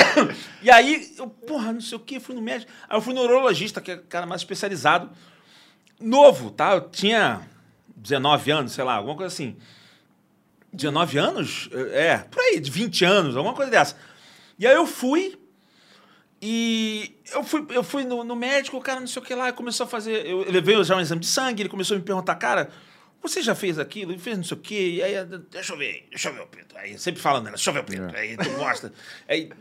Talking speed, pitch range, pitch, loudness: 225 wpm, 180-255 Hz, 210 Hz, -22 LUFS